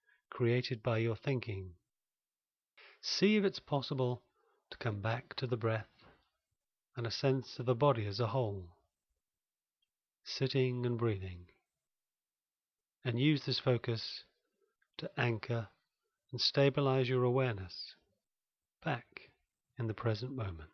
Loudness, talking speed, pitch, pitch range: -35 LUFS, 120 wpm, 125 Hz, 110-130 Hz